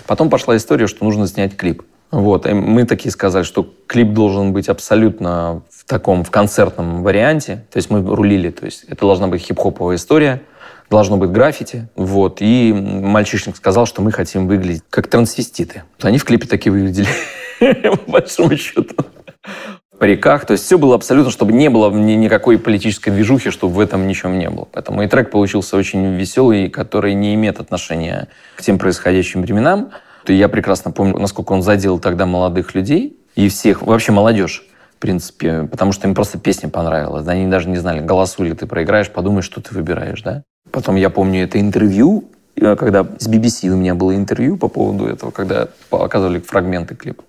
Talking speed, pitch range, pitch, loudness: 180 wpm, 95-105 Hz, 100 Hz, -15 LUFS